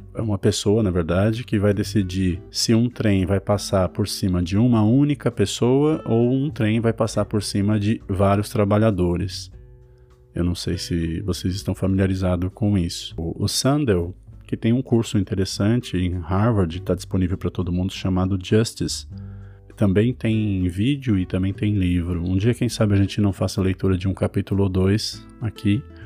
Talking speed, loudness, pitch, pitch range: 175 wpm, -21 LUFS, 100 Hz, 95-110 Hz